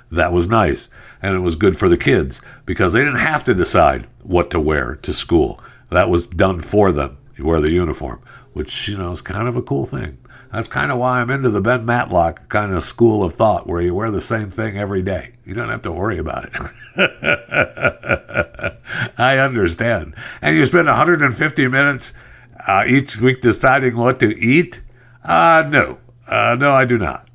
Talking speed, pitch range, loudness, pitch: 195 wpm, 90-125 Hz, -17 LUFS, 115 Hz